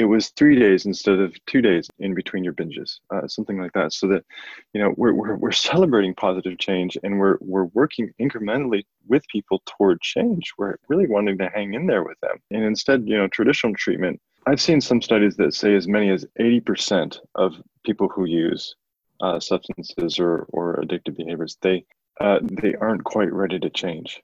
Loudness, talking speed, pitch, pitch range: -21 LUFS, 195 wpm, 100 Hz, 95-110 Hz